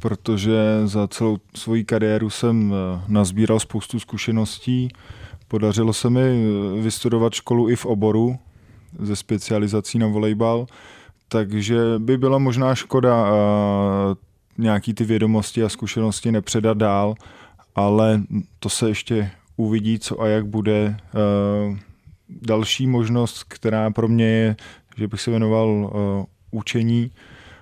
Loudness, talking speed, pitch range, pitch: -20 LUFS, 115 wpm, 105-115 Hz, 110 Hz